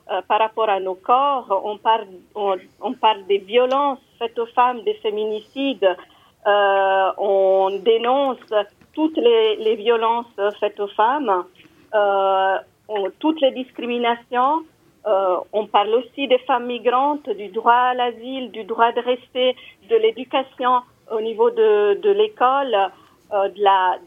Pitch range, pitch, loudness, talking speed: 200-270 Hz, 235 Hz, -20 LUFS, 140 wpm